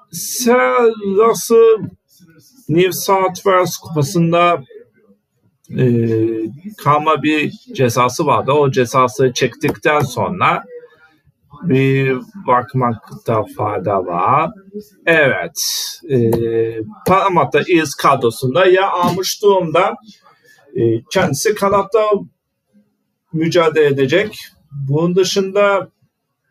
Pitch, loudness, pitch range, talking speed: 170 Hz, -15 LUFS, 135-200 Hz, 75 wpm